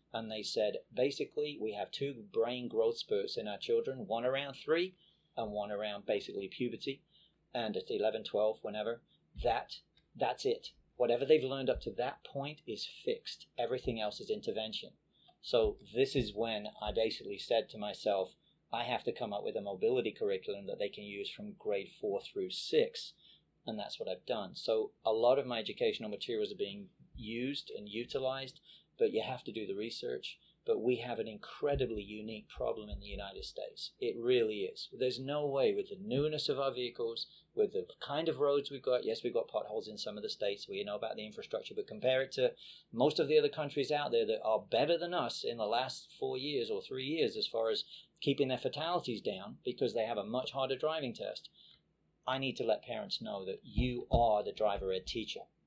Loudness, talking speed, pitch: -36 LUFS, 205 wpm, 370 Hz